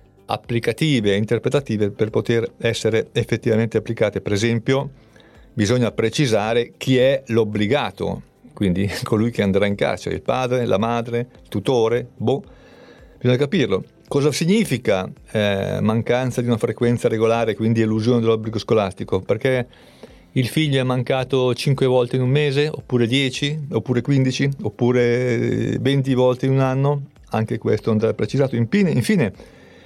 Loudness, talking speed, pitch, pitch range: -20 LUFS, 135 wpm, 120 Hz, 110-130 Hz